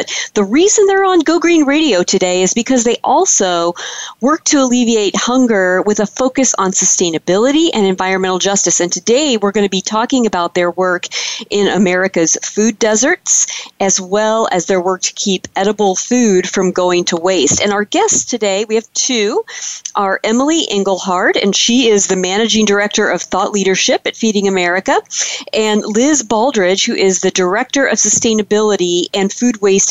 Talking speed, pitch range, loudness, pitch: 175 wpm, 190-245 Hz, -13 LUFS, 210 Hz